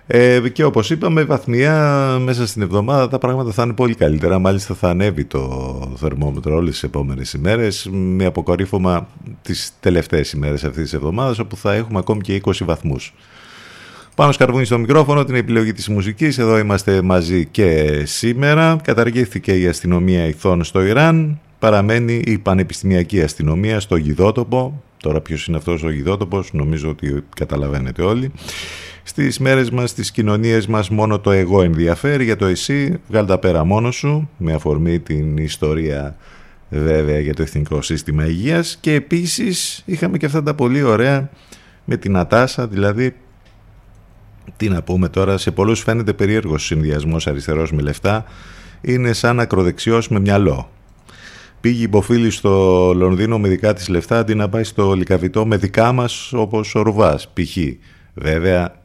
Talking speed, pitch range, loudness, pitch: 155 wpm, 85-120 Hz, -17 LUFS, 100 Hz